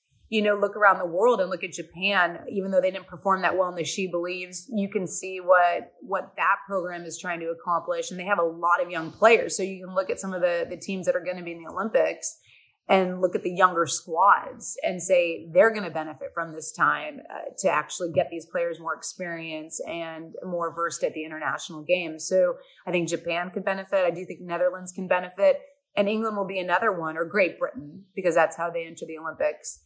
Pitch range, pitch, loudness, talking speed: 170-195 Hz, 180 Hz, -26 LUFS, 235 wpm